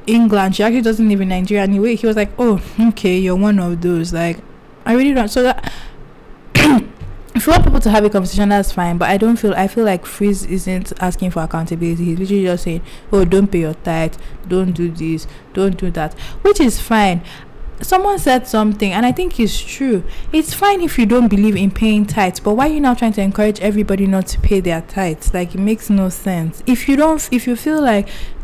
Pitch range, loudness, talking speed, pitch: 185-230 Hz, -15 LUFS, 225 wpm, 200 Hz